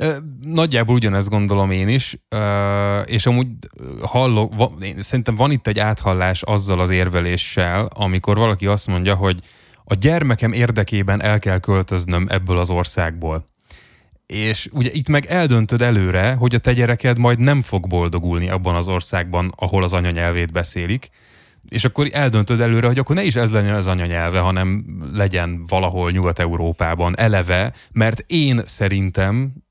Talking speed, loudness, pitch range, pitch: 145 wpm, -18 LUFS, 90-120 Hz, 100 Hz